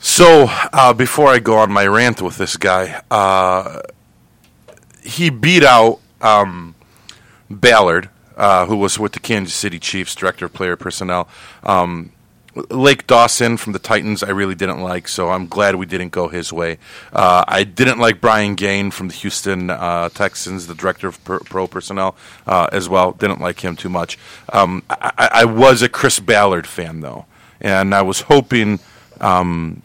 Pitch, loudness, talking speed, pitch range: 95 Hz, -14 LUFS, 170 wpm, 90-110 Hz